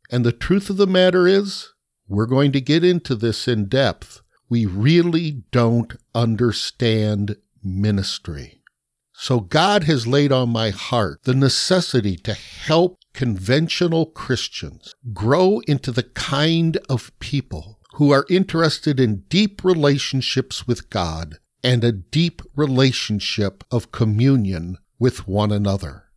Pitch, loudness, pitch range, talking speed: 125 Hz, -19 LUFS, 110-150 Hz, 130 wpm